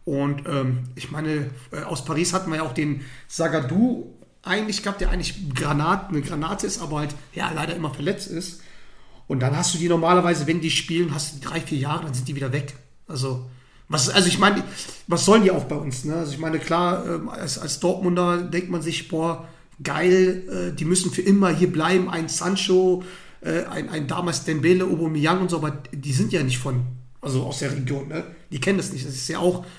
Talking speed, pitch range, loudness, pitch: 220 wpm, 145-180 Hz, -23 LUFS, 165 Hz